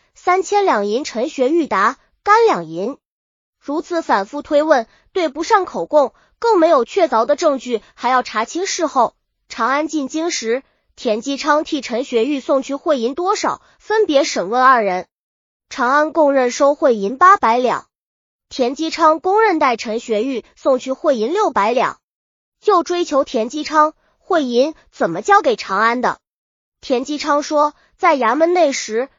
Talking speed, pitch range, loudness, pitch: 225 characters per minute, 250-335 Hz, -17 LUFS, 295 Hz